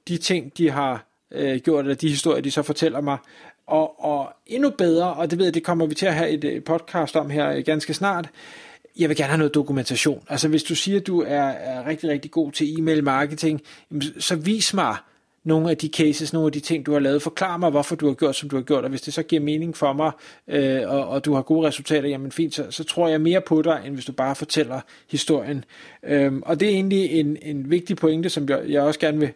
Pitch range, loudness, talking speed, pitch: 145-165 Hz, -22 LUFS, 245 wpm, 155 Hz